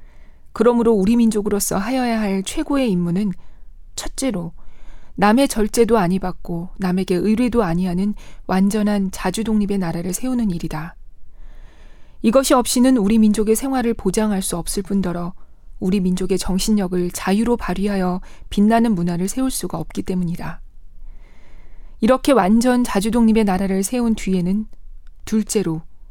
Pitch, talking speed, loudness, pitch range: 200 Hz, 315 characters per minute, -19 LUFS, 185-230 Hz